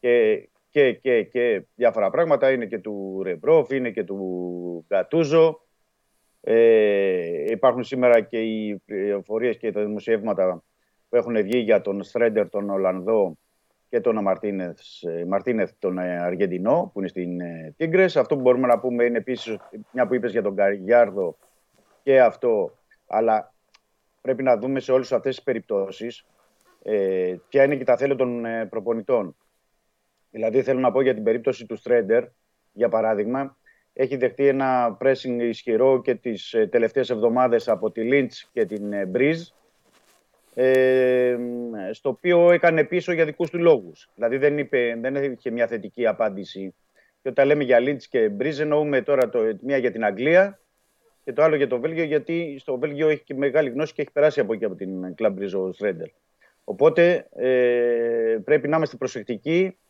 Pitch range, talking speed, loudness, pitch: 110-155 Hz, 155 wpm, -22 LUFS, 130 Hz